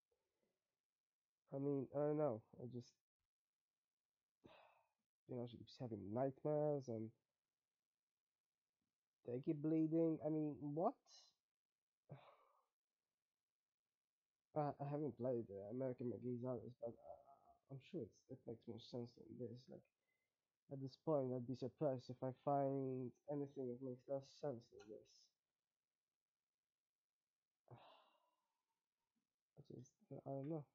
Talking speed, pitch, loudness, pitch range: 120 wpm, 135 Hz, -47 LUFS, 125-150 Hz